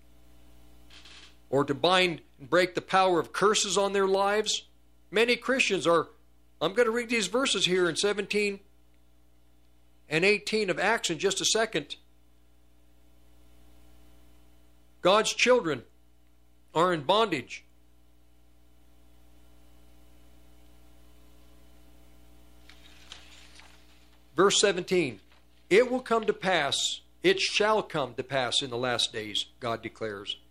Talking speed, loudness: 110 wpm, -26 LUFS